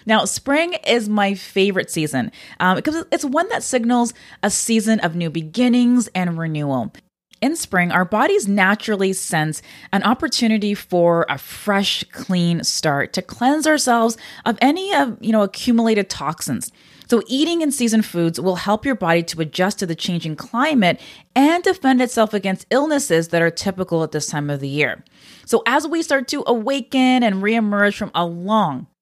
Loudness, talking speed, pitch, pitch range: -19 LUFS, 170 wpm, 210 Hz, 180-250 Hz